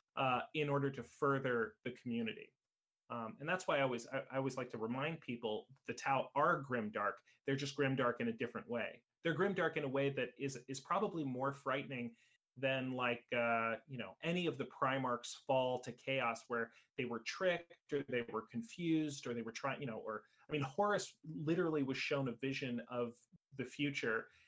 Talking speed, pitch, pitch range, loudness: 195 wpm, 135 Hz, 120-150 Hz, -40 LUFS